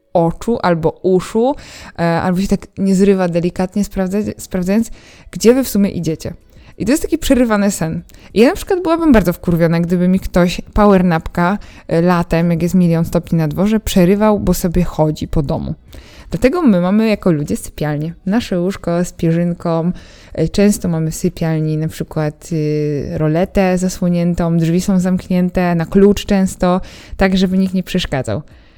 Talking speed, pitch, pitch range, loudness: 165 wpm, 180 Hz, 165-200 Hz, -15 LUFS